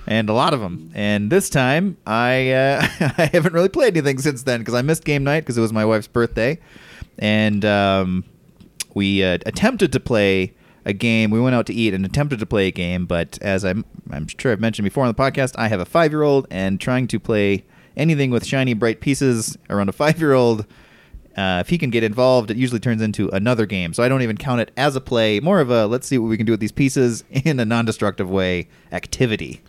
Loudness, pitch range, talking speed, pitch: -19 LUFS, 105-135 Hz, 240 wpm, 115 Hz